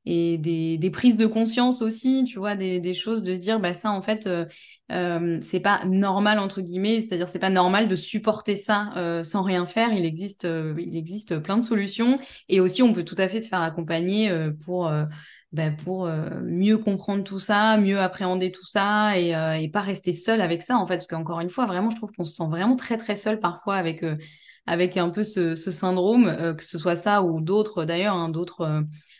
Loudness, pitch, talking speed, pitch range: -24 LUFS, 185 Hz, 235 wpm, 170-210 Hz